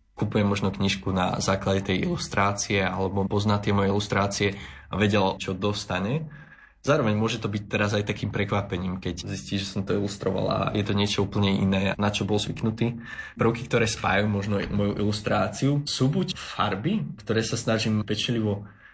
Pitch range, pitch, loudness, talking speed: 100-110 Hz, 105 Hz, -26 LUFS, 170 wpm